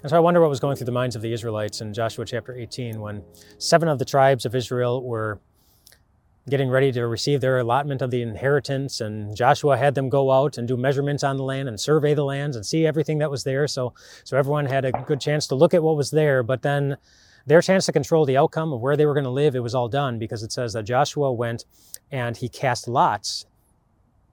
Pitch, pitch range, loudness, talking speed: 135 Hz, 120-145 Hz, -22 LUFS, 240 wpm